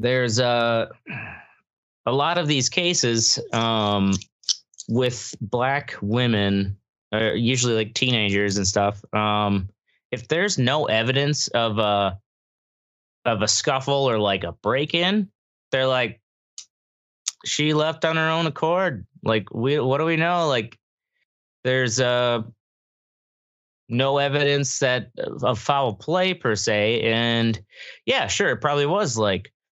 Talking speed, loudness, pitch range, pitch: 130 wpm, -22 LUFS, 105-140 Hz, 120 Hz